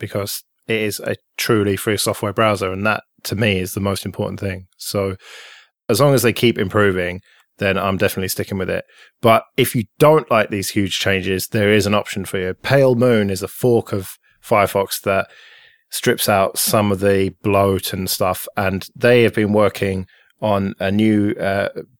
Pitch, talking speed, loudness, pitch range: 100 Hz, 190 wpm, -18 LUFS, 95-110 Hz